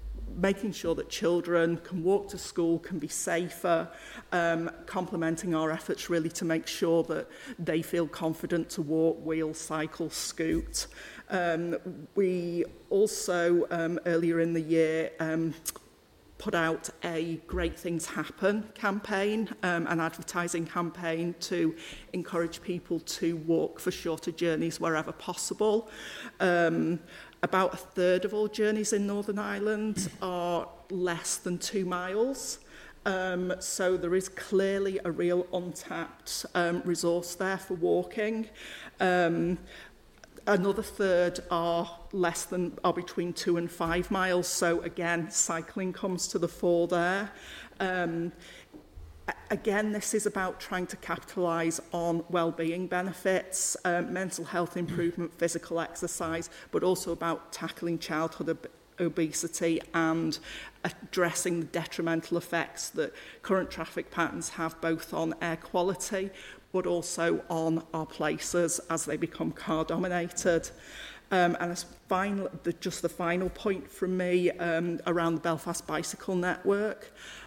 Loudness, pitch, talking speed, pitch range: -31 LUFS, 175 Hz, 135 wpm, 165-185 Hz